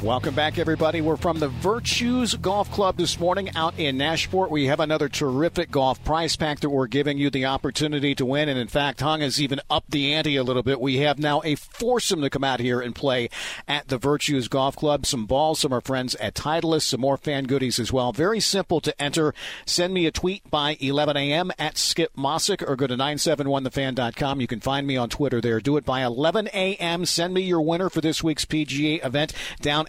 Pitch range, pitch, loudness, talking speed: 135-160 Hz, 150 Hz, -23 LUFS, 220 wpm